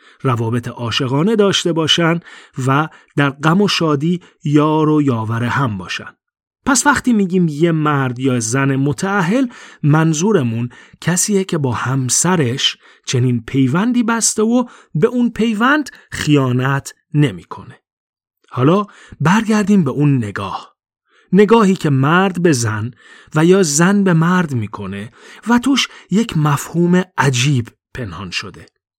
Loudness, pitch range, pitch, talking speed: -15 LUFS, 135-195 Hz, 160 Hz, 120 wpm